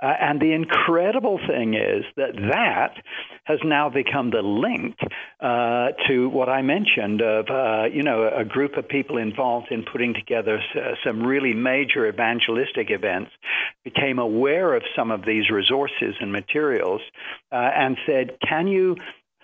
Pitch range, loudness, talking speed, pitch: 115-155 Hz, -22 LUFS, 155 wpm, 130 Hz